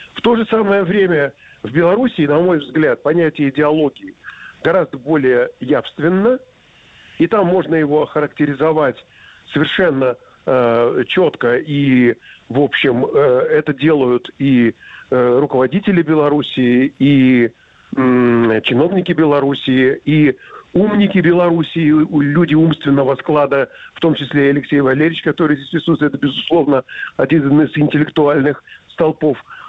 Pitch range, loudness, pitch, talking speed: 135-170 Hz, -13 LUFS, 150 Hz, 115 wpm